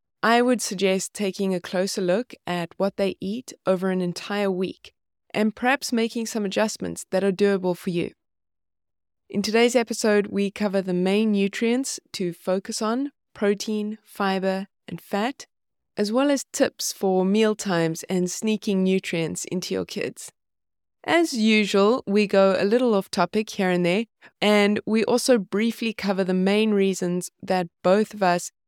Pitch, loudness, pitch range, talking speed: 200 Hz, -23 LUFS, 185-220 Hz, 160 wpm